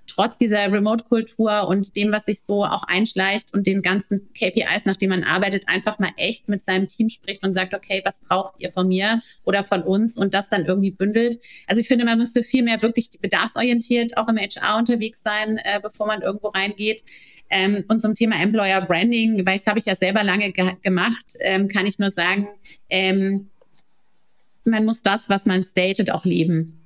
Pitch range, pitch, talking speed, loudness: 190-220 Hz, 200 Hz, 195 wpm, -21 LUFS